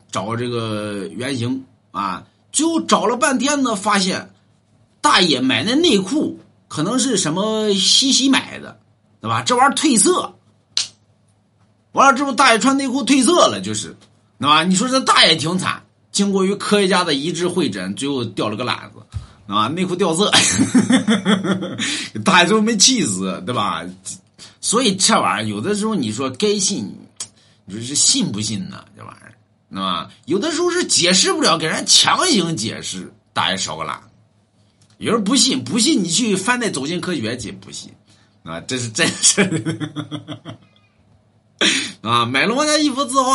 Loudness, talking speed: -16 LUFS, 240 characters per minute